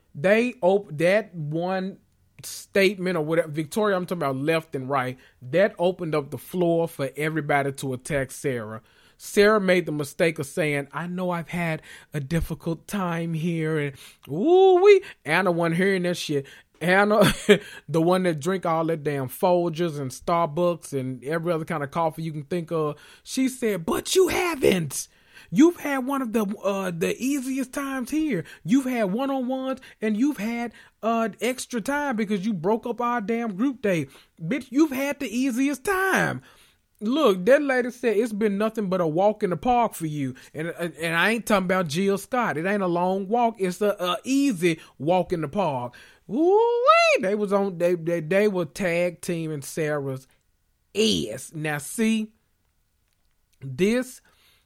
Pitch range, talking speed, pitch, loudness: 160-230 Hz, 175 wpm, 185 Hz, -24 LUFS